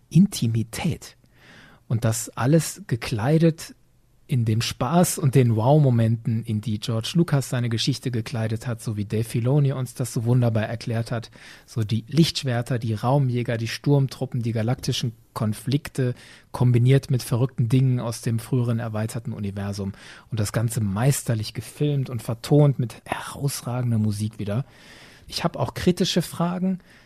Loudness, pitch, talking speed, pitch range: -24 LUFS, 125 Hz, 140 wpm, 115-135 Hz